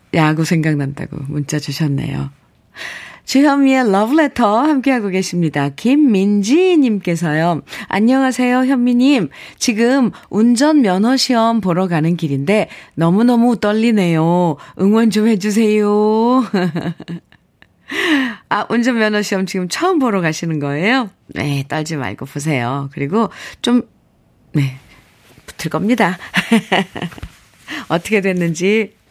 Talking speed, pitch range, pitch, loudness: 240 characters per minute, 160-240 Hz, 200 Hz, -15 LUFS